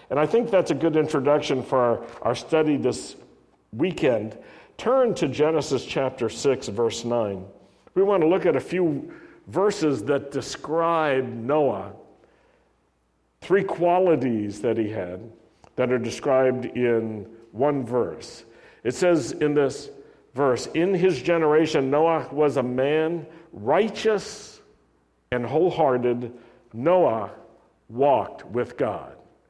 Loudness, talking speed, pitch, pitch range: -23 LUFS, 120 wpm, 140 Hz, 120-170 Hz